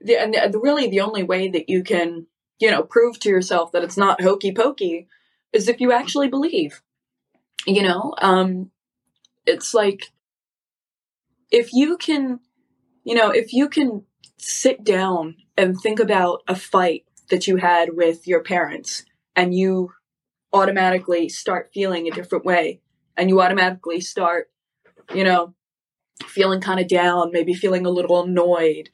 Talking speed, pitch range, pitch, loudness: 150 wpm, 175-230 Hz, 190 Hz, -19 LUFS